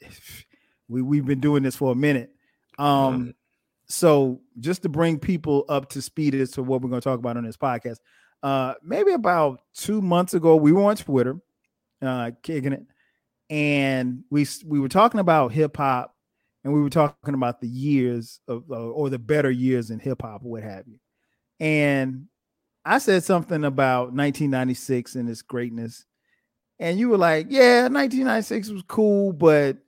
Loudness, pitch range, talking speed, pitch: -22 LUFS, 125-165 Hz, 170 wpm, 140 Hz